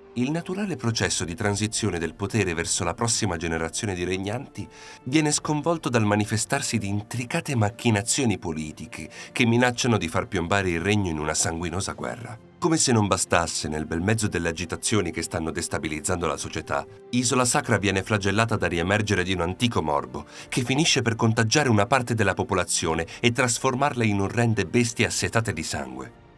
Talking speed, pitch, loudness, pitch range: 165 wpm, 105 Hz, -24 LUFS, 90-120 Hz